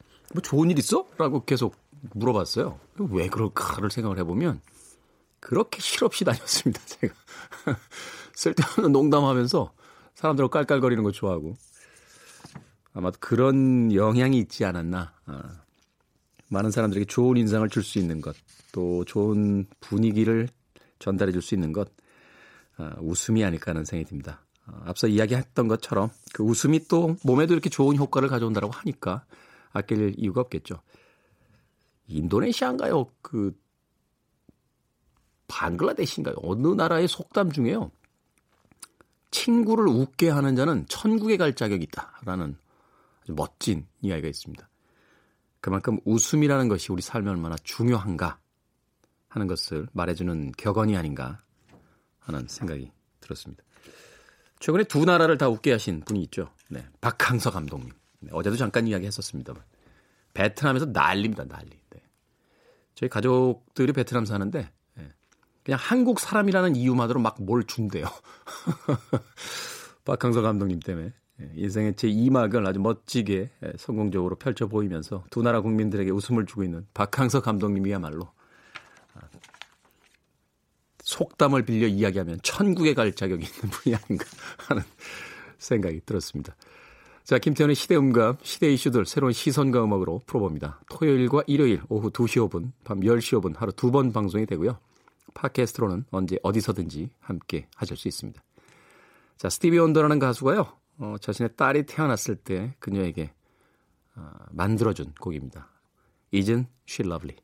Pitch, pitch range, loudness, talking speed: 110 Hz, 95-130 Hz, -25 LUFS, 315 characters per minute